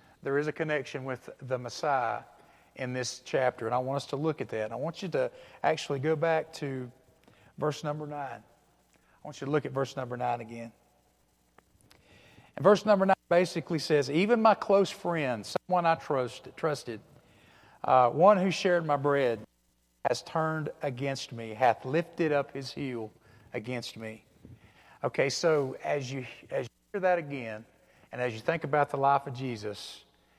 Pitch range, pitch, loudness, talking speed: 120-160 Hz, 140 Hz, -30 LUFS, 180 wpm